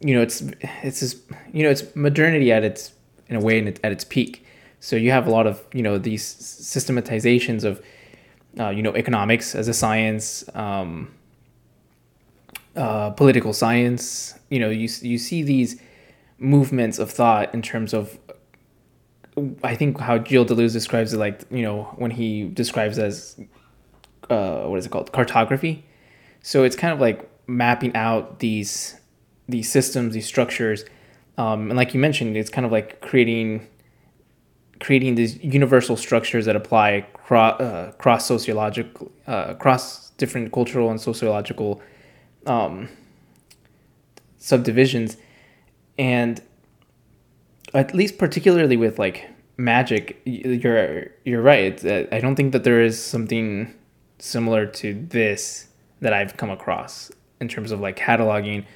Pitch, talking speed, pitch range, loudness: 115 Hz, 145 wpm, 110-130 Hz, -21 LUFS